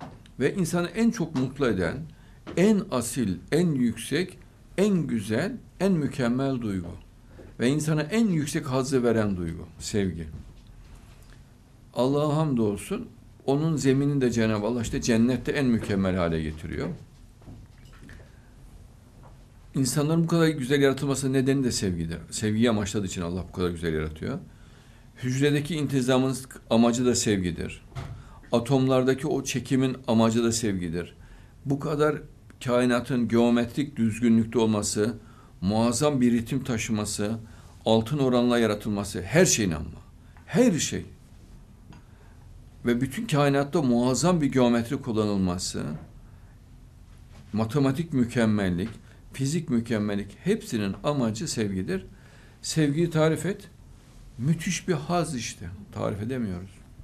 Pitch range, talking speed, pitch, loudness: 105-135 Hz, 110 wpm, 120 Hz, -26 LUFS